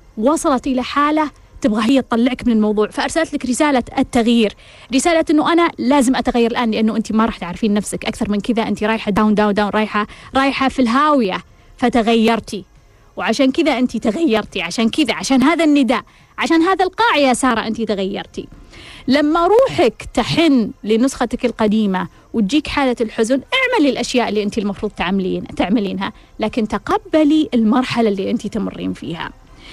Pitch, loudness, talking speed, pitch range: 240 Hz, -16 LUFS, 150 wpm, 215-275 Hz